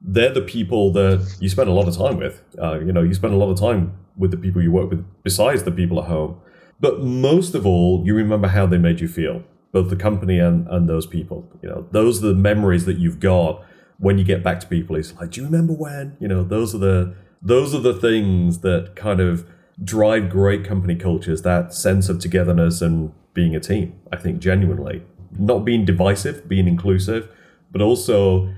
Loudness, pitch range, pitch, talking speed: -19 LUFS, 85-100 Hz, 95 Hz, 220 wpm